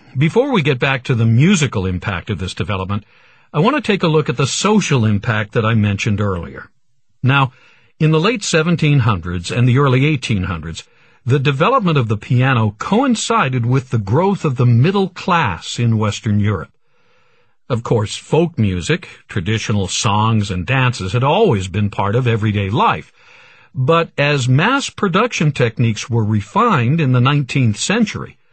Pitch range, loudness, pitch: 105-155 Hz, -16 LUFS, 125 Hz